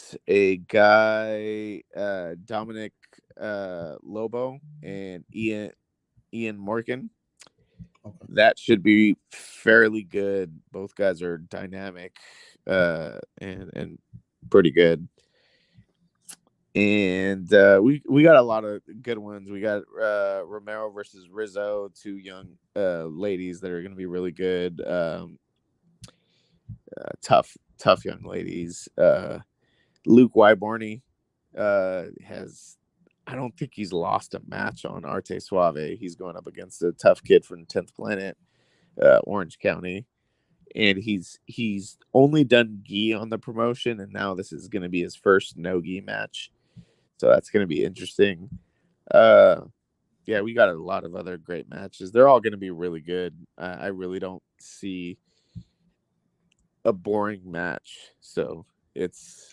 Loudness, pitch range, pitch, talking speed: -23 LUFS, 90-110 Hz, 100 Hz, 140 wpm